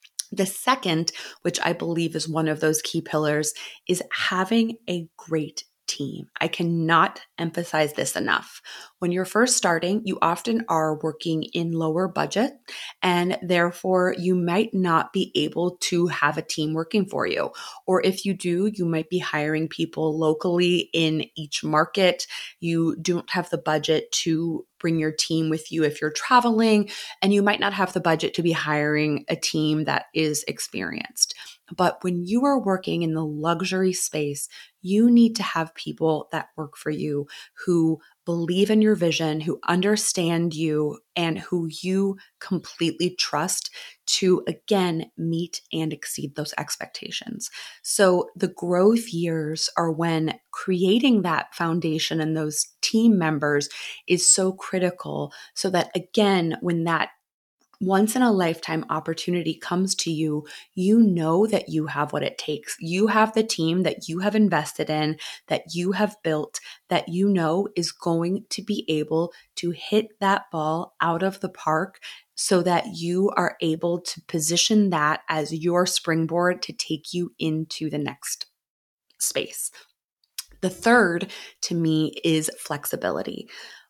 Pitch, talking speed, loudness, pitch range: 170 Hz, 155 wpm, -24 LUFS, 160-190 Hz